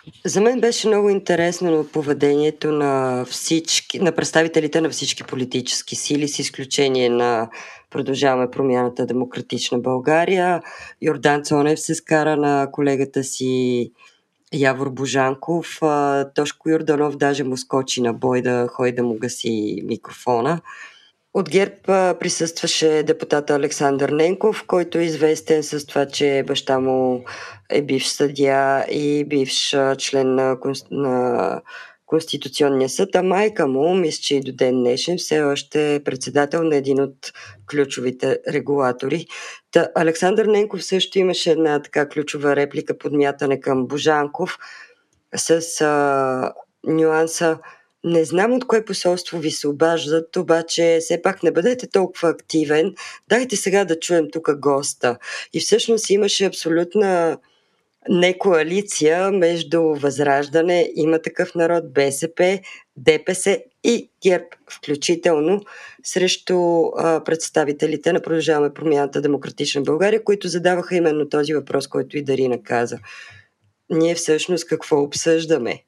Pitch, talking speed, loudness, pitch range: 155 Hz, 125 wpm, -19 LUFS, 140-170 Hz